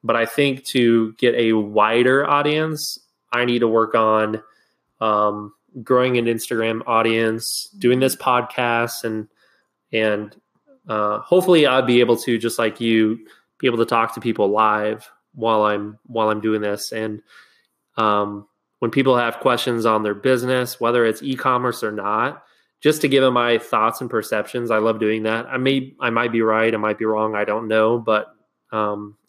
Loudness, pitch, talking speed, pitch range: -19 LUFS, 115 Hz, 175 wpm, 110-125 Hz